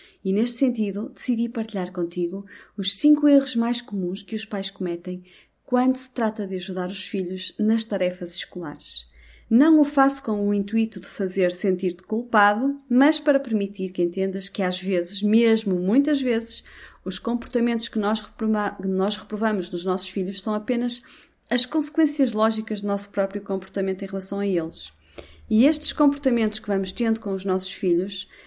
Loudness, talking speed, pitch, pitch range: -23 LUFS, 165 wpm, 205 Hz, 190-235 Hz